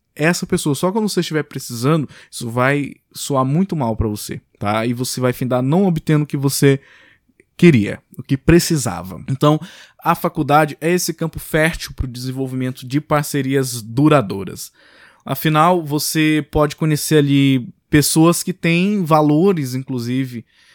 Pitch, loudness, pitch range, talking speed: 150 Hz, -17 LUFS, 130-165 Hz, 145 wpm